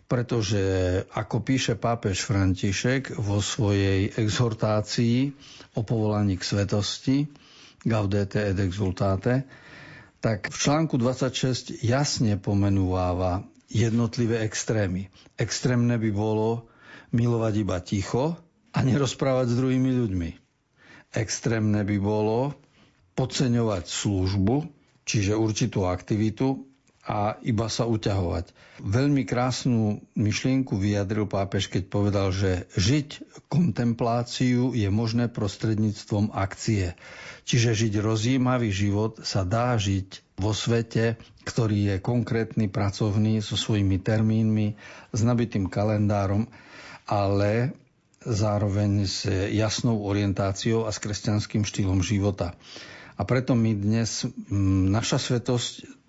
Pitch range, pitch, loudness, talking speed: 100-125 Hz, 110 Hz, -25 LUFS, 105 wpm